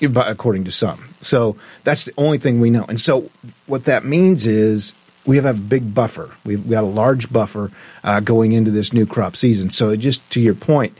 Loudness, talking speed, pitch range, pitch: -16 LUFS, 200 wpm, 110-135 Hz, 115 Hz